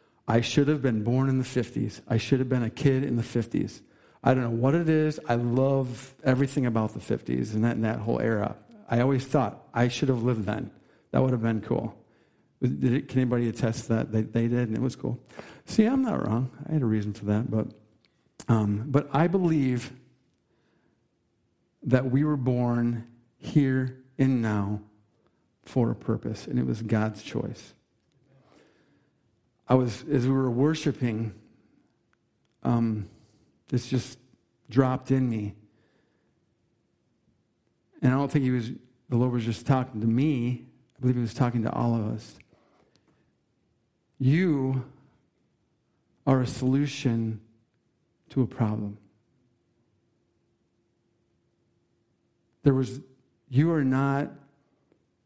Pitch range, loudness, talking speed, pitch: 115-135 Hz, -27 LUFS, 150 wpm, 125 Hz